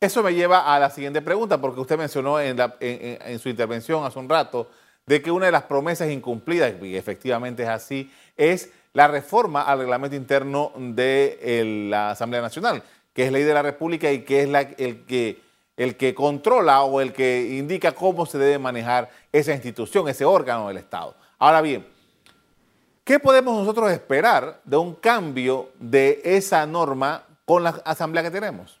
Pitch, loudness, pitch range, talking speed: 140 Hz, -21 LUFS, 125-160 Hz, 185 wpm